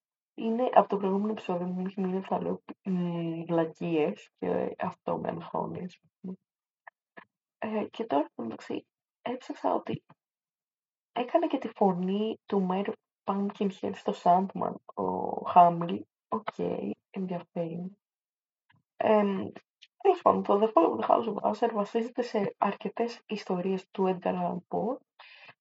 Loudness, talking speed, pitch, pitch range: -30 LUFS, 115 wpm, 200 Hz, 180-225 Hz